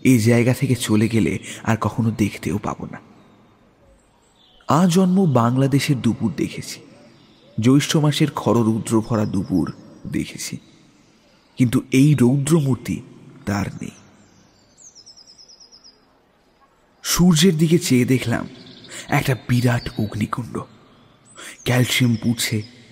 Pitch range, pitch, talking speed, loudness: 110-135 Hz, 120 Hz, 90 wpm, -19 LUFS